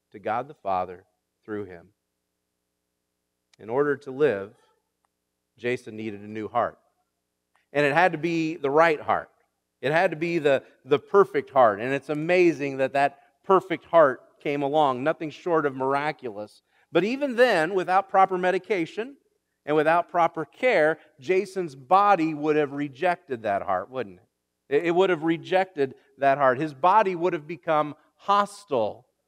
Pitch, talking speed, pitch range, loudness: 155 Hz, 155 wpm, 130-180 Hz, -24 LUFS